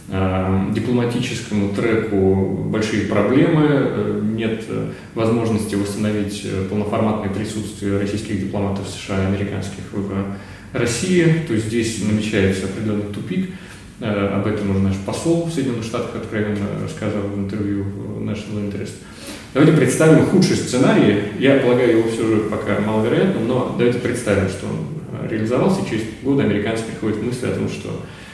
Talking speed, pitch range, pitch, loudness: 135 wpm, 100-115 Hz, 105 Hz, -19 LUFS